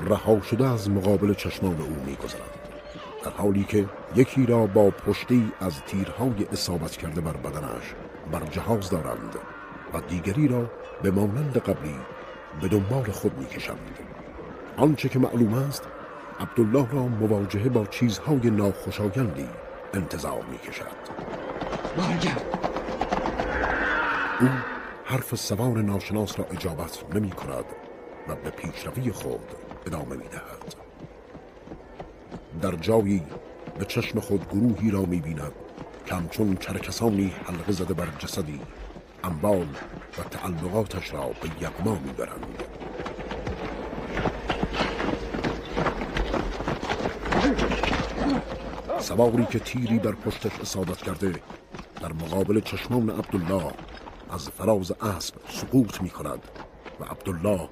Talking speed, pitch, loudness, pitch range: 110 wpm, 100 Hz, -27 LUFS, 90-115 Hz